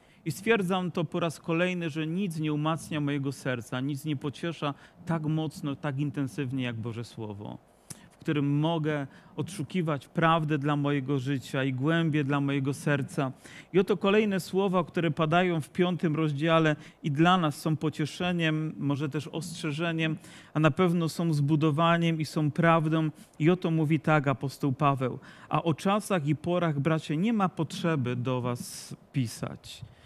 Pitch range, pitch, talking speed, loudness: 145-170 Hz, 155 Hz, 155 wpm, -28 LUFS